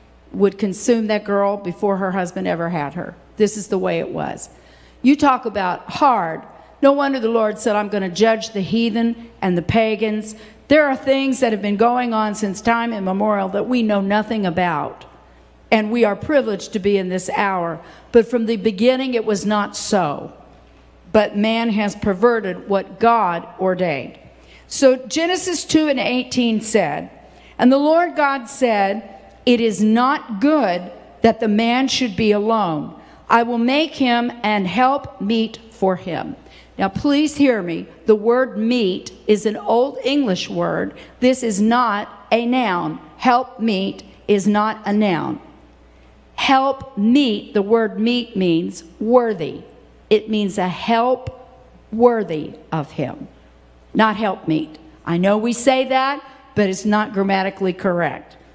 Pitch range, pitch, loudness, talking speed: 195-240 Hz, 215 Hz, -18 LUFS, 160 wpm